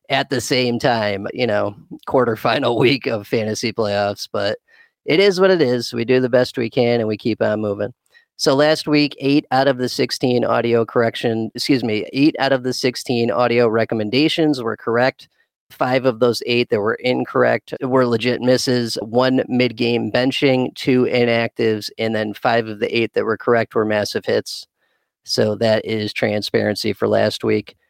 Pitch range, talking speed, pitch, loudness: 110-130 Hz, 180 wpm, 120 Hz, -18 LUFS